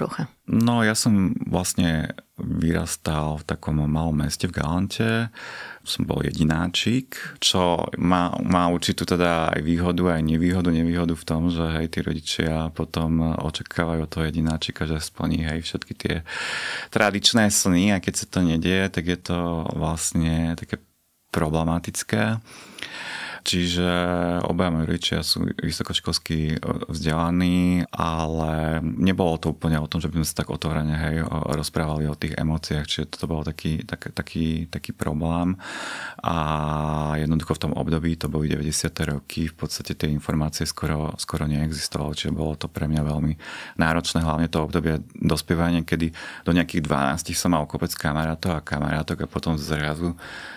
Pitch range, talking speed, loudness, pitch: 80-90 Hz, 150 wpm, -24 LUFS, 80 Hz